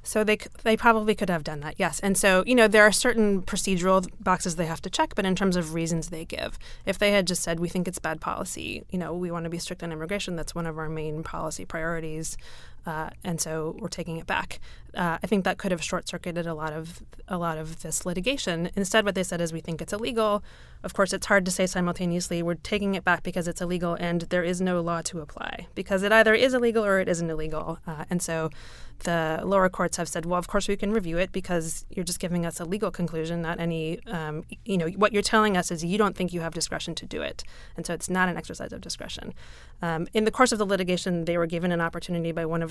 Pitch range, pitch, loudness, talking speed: 165-195 Hz, 180 Hz, -26 LUFS, 255 wpm